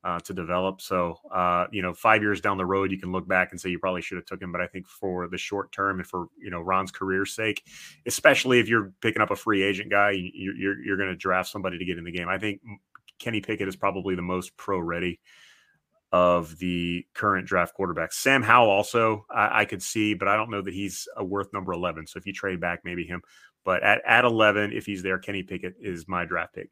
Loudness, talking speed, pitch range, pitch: -25 LUFS, 245 wpm, 90-100 Hz, 95 Hz